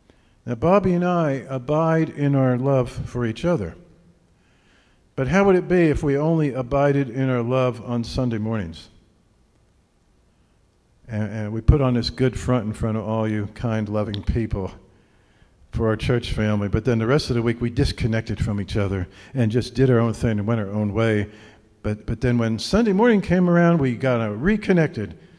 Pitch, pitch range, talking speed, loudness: 120 Hz, 110-140 Hz, 190 wpm, -22 LUFS